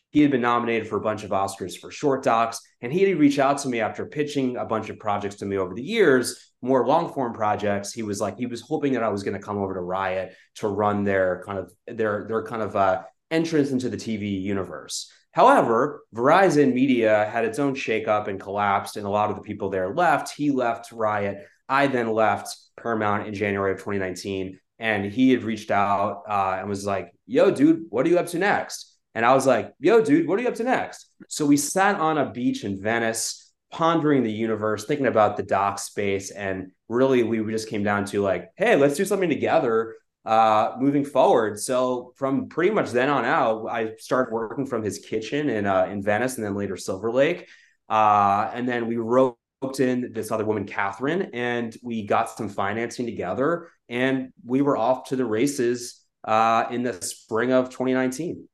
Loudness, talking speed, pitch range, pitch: -23 LUFS, 210 wpm, 105-130 Hz, 115 Hz